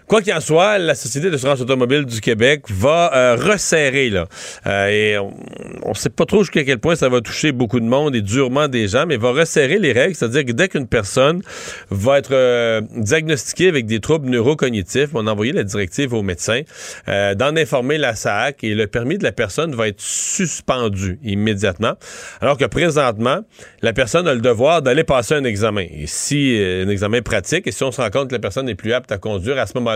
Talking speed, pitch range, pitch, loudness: 220 wpm, 110-145 Hz, 125 Hz, -17 LUFS